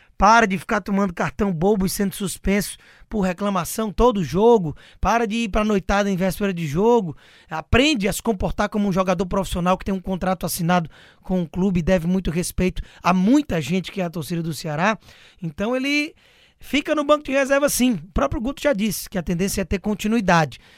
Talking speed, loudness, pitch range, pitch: 210 wpm, -21 LUFS, 180-225 Hz, 195 Hz